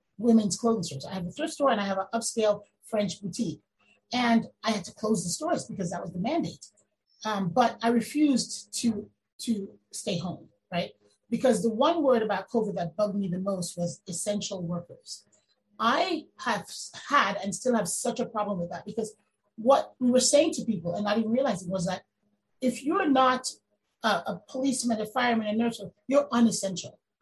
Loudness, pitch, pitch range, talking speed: -28 LUFS, 215 Hz, 190-245 Hz, 190 wpm